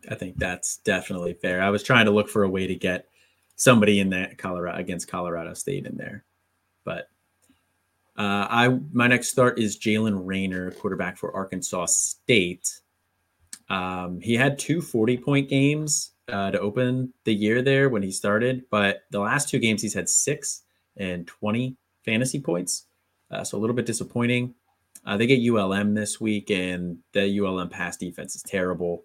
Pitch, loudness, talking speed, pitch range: 105 Hz, -24 LUFS, 175 wpm, 95-120 Hz